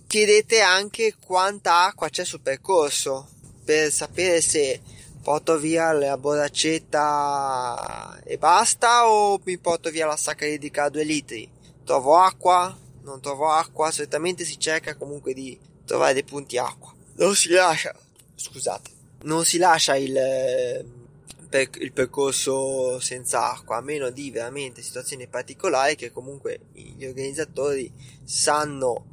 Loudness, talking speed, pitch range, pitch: -22 LUFS, 130 wpm, 135-175 Hz, 150 Hz